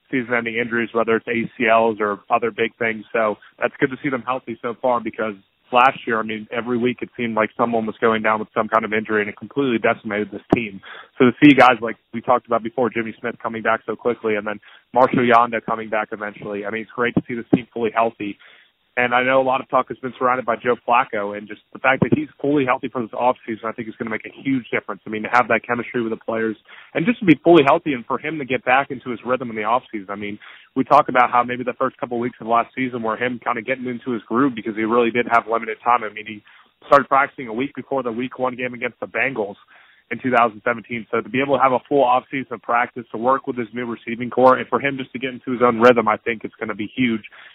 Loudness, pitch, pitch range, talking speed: -20 LUFS, 120 Hz, 110-125 Hz, 280 wpm